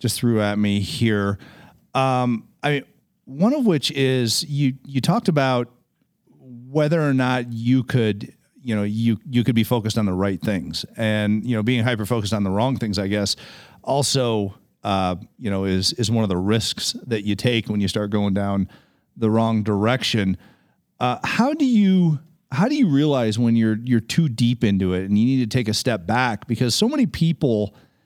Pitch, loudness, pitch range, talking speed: 120 Hz, -21 LUFS, 105-130 Hz, 195 wpm